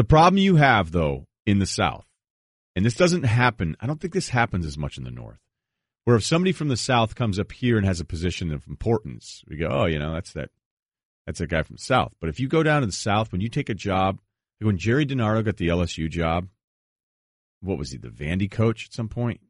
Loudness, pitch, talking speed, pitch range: -23 LUFS, 105 Hz, 245 wpm, 85-120 Hz